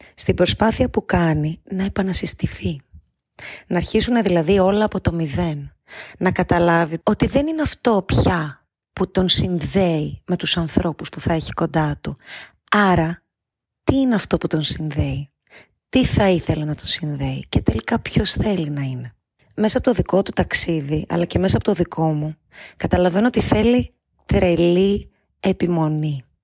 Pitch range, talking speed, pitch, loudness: 155-195 Hz, 155 wpm, 175 Hz, -19 LUFS